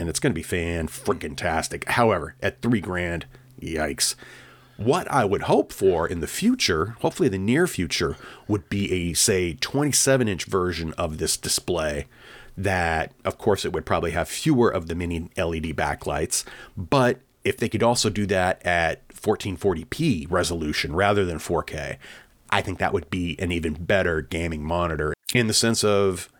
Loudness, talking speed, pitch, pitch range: -24 LUFS, 170 wpm, 90 Hz, 85-115 Hz